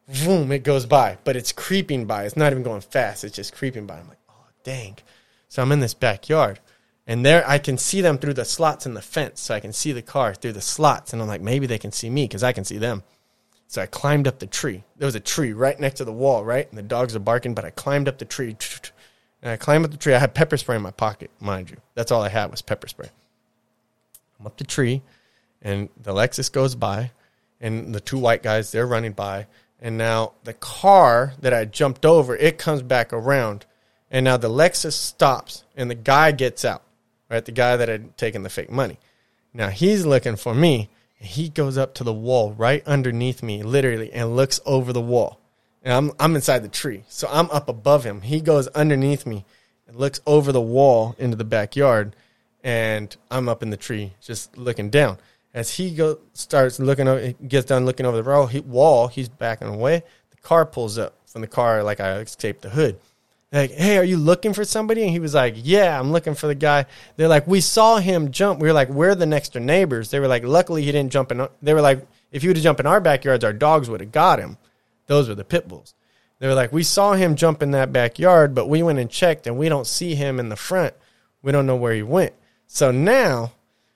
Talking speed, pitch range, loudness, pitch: 235 wpm, 115-145 Hz, -20 LUFS, 130 Hz